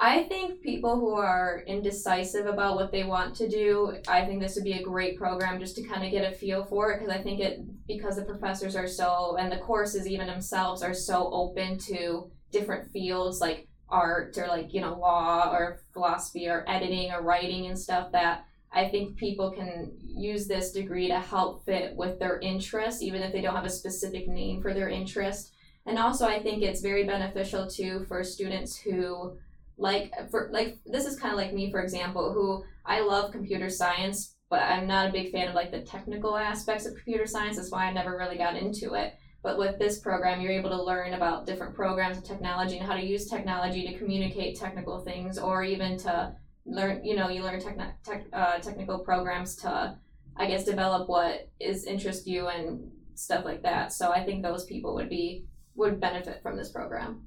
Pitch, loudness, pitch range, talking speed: 190 Hz, -30 LUFS, 180-200 Hz, 205 wpm